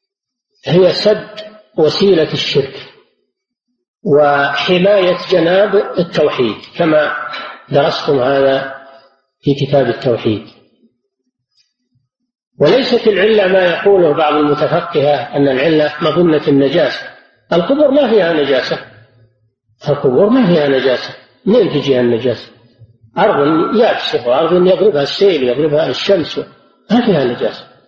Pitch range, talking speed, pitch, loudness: 135-200 Hz, 95 wpm, 150 Hz, -13 LUFS